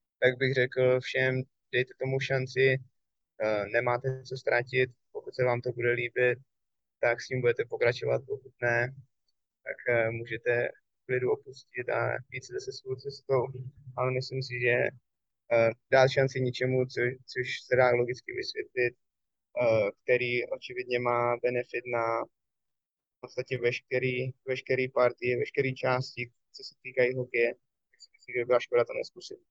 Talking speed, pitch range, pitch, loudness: 135 wpm, 120-135 Hz, 130 Hz, -29 LUFS